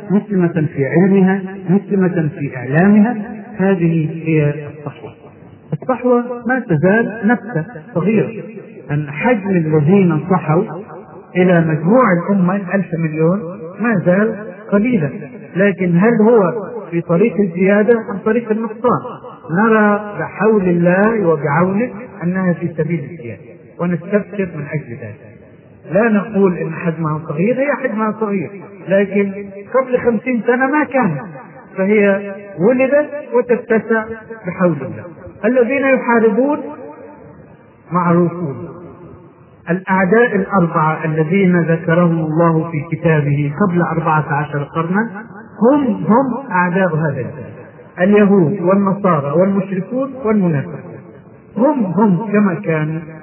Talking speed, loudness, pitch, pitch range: 105 wpm, -15 LUFS, 190 Hz, 165-220 Hz